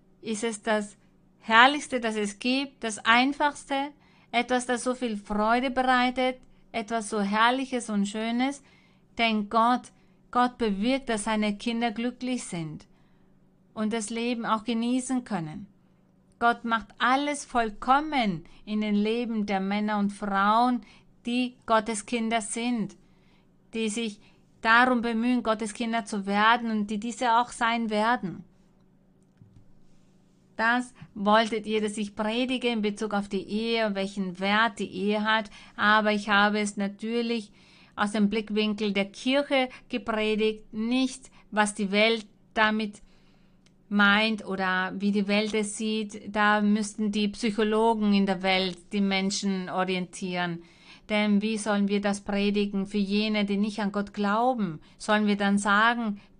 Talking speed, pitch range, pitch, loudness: 140 wpm, 200-235 Hz, 215 Hz, -26 LUFS